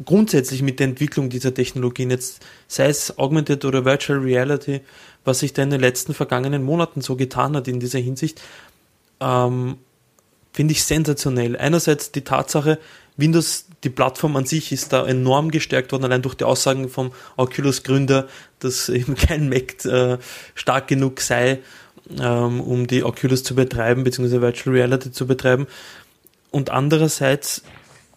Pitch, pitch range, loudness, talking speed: 135 Hz, 125-145 Hz, -20 LUFS, 150 wpm